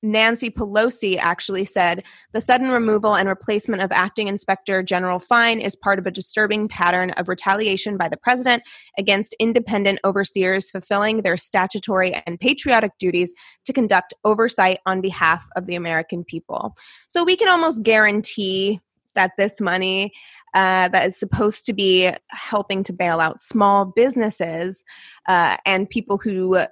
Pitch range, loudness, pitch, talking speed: 185-220 Hz, -19 LUFS, 195 Hz, 150 wpm